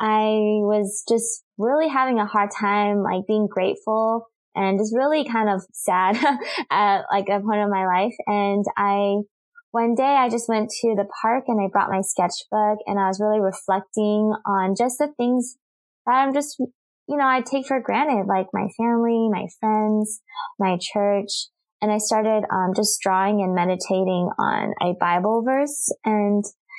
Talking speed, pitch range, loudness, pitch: 170 wpm, 200-230 Hz, -22 LUFS, 210 Hz